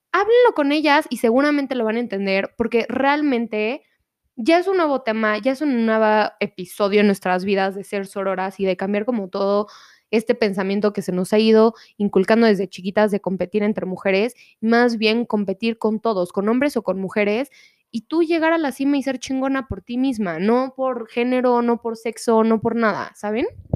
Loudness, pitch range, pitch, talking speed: -20 LUFS, 205-255 Hz, 225 Hz, 195 wpm